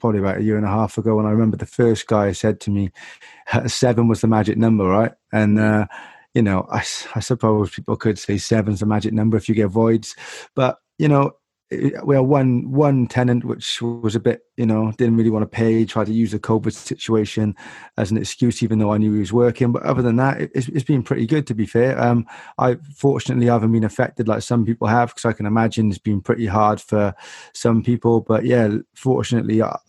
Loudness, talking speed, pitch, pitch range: -19 LUFS, 235 wpm, 115 Hz, 110-120 Hz